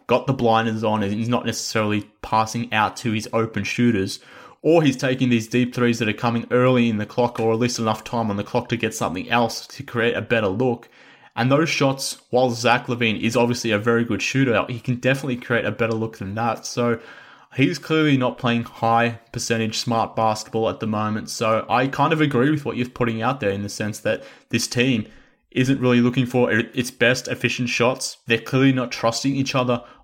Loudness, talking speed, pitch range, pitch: -21 LUFS, 215 wpm, 110-125 Hz, 120 Hz